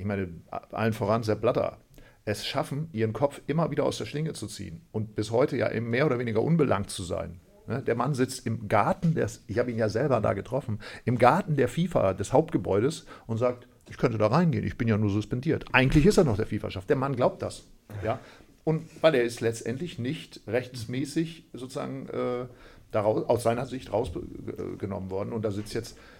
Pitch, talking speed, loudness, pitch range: 120 Hz, 195 wpm, -28 LUFS, 110-140 Hz